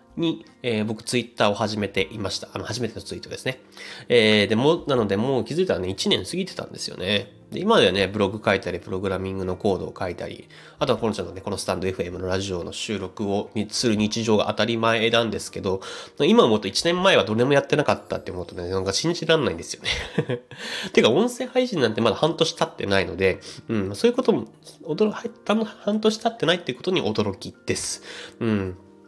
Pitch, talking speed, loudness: 110 Hz, 435 characters per minute, -23 LUFS